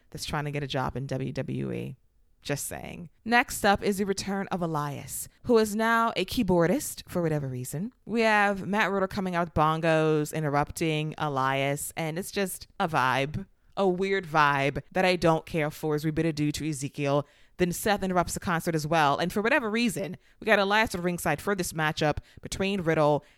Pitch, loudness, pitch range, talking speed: 165 Hz, -27 LUFS, 145-195 Hz, 190 wpm